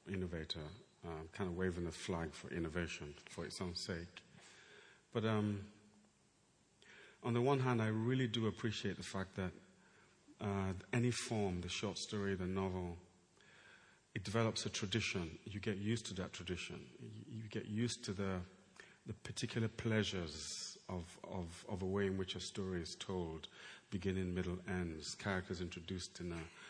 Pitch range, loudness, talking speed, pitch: 90-110 Hz, -42 LUFS, 155 wpm, 95 Hz